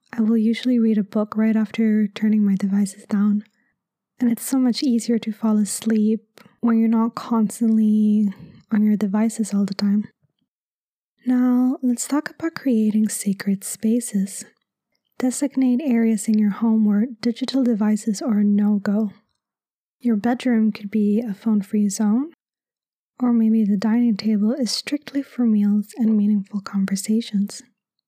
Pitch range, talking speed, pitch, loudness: 210-235 Hz, 145 wpm, 220 Hz, -21 LUFS